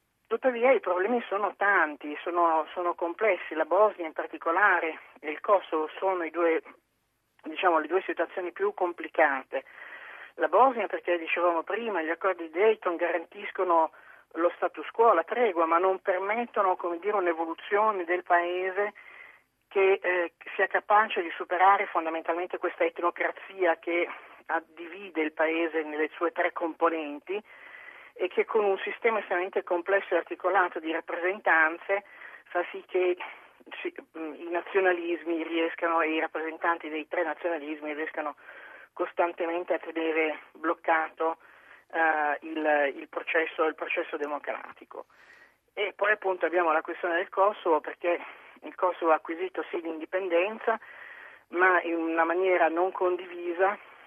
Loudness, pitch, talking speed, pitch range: -28 LUFS, 175 Hz, 135 wpm, 165-190 Hz